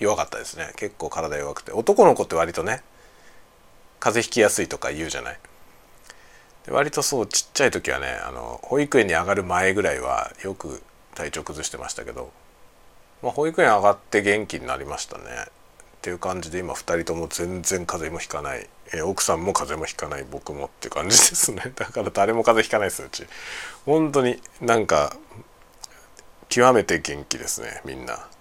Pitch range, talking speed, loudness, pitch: 85-115 Hz, 360 characters per minute, -22 LUFS, 100 Hz